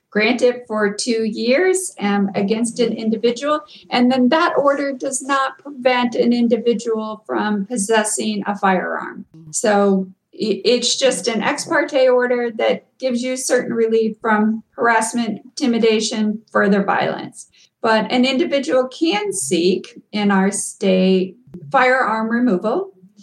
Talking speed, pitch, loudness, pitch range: 125 wpm, 230 Hz, -18 LUFS, 205-255 Hz